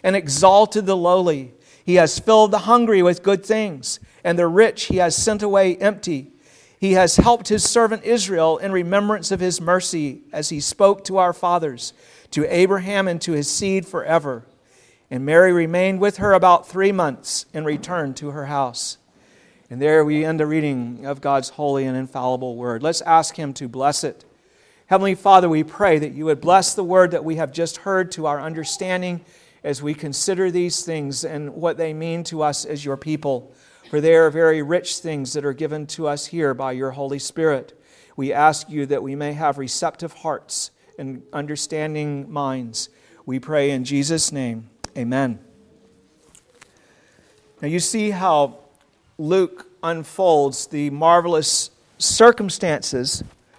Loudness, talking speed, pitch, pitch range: -19 LUFS, 170 wpm, 160 Hz, 140-180 Hz